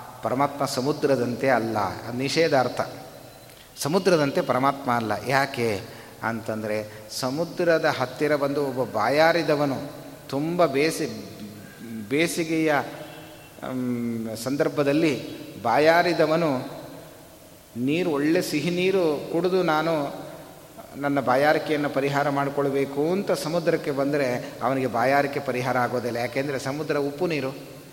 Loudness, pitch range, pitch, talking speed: -24 LUFS, 125-155 Hz, 140 Hz, 85 wpm